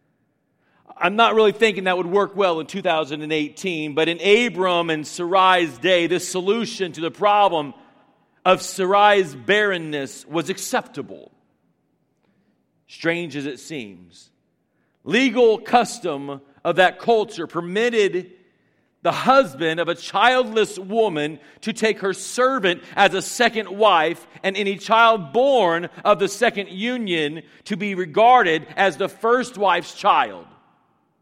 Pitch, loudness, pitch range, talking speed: 190 Hz, -19 LUFS, 165-215 Hz, 125 wpm